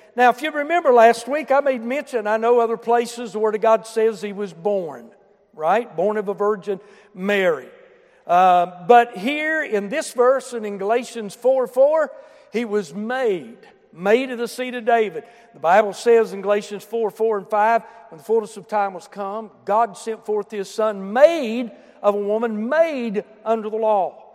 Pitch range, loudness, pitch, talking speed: 210-250 Hz, -20 LUFS, 225 Hz, 180 wpm